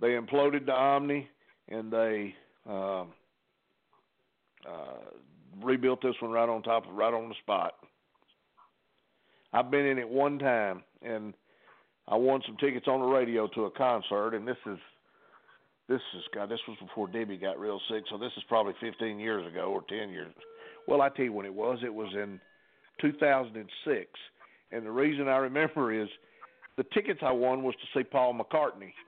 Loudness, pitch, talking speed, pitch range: -31 LUFS, 115 Hz, 175 wpm, 110-130 Hz